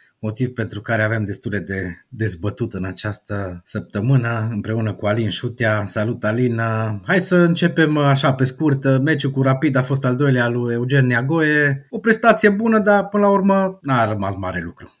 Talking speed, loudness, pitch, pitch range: 170 wpm, -19 LUFS, 120 Hz, 105-145 Hz